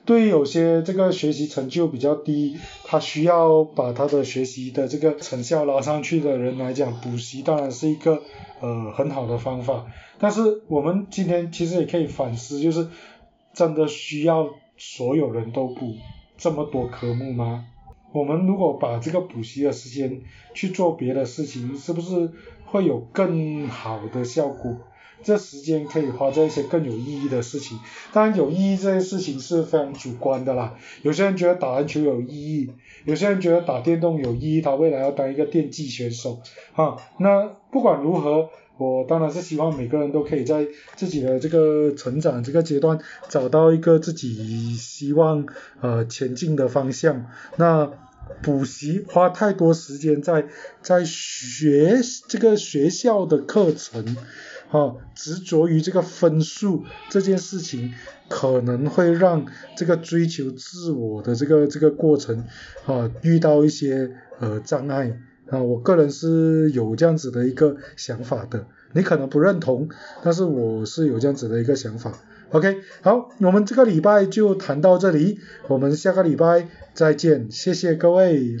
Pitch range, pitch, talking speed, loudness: 130-170 Hz, 150 Hz, 250 characters per minute, -21 LUFS